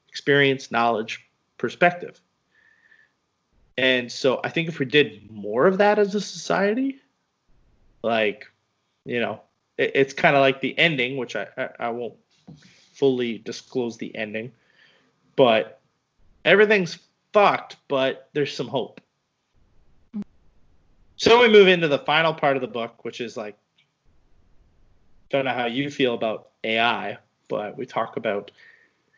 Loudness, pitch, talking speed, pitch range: -22 LUFS, 130 Hz, 135 wpm, 110-170 Hz